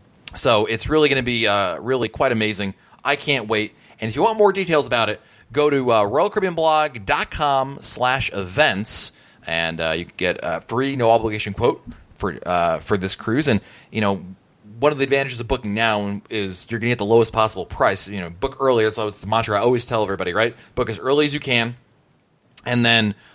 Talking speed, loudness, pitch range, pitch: 215 wpm, -20 LUFS, 105-135 Hz, 115 Hz